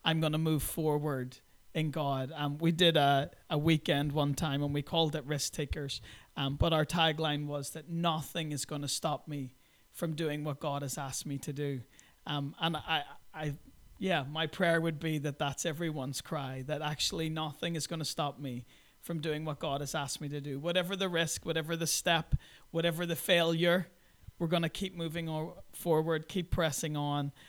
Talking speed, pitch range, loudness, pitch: 200 wpm, 145-165 Hz, -33 LUFS, 155 Hz